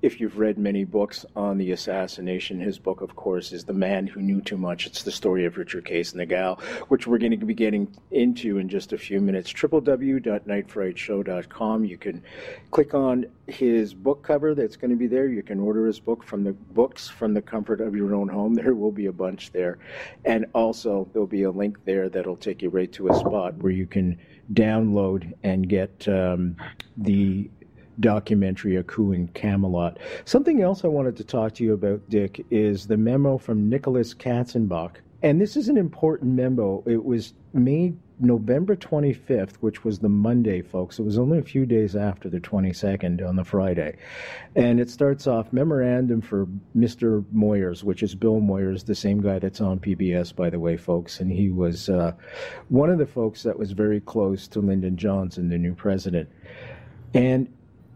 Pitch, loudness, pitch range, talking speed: 105 Hz, -24 LUFS, 95-120 Hz, 195 wpm